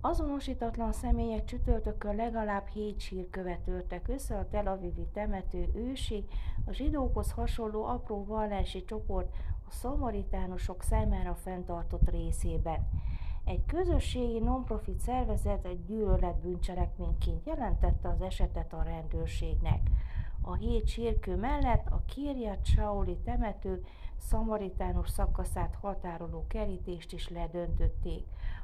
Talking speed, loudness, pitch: 100 wpm, -35 LUFS, 170 Hz